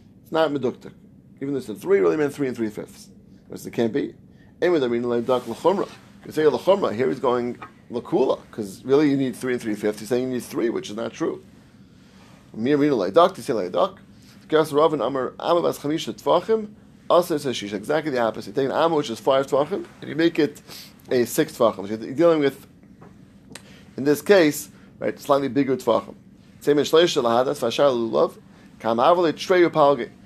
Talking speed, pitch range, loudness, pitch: 175 wpm, 120-155 Hz, -22 LUFS, 135 Hz